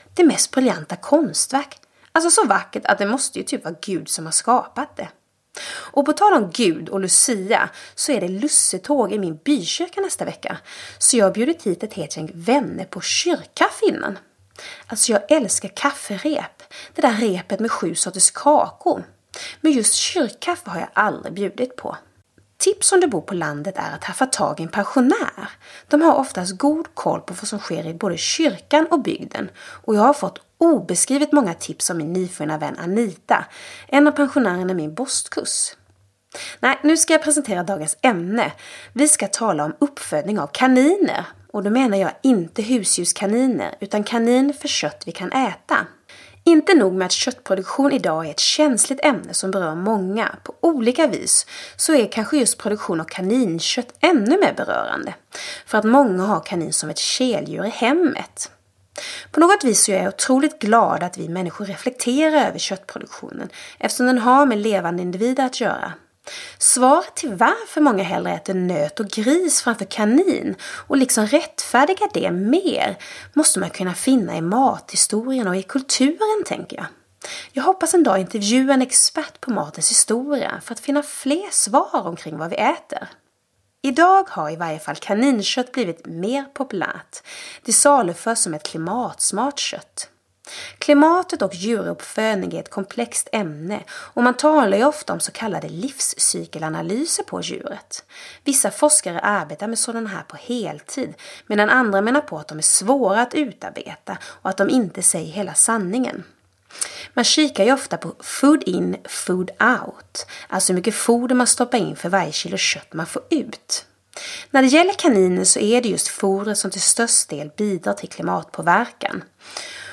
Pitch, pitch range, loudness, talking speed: 240 Hz, 195-290 Hz, -19 LUFS, 170 wpm